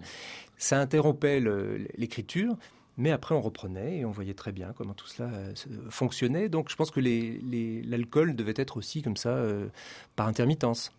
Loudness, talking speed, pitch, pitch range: -30 LUFS, 175 wpm, 120 Hz, 110-145 Hz